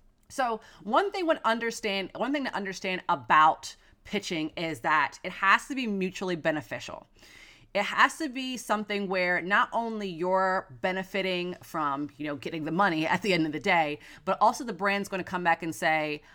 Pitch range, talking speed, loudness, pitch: 165-210 Hz, 185 wpm, -28 LUFS, 190 Hz